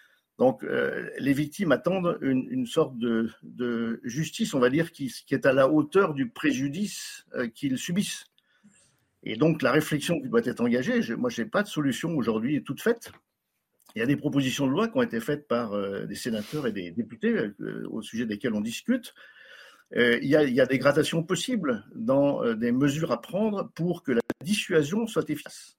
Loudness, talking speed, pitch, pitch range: -27 LUFS, 205 wpm, 170 Hz, 140-230 Hz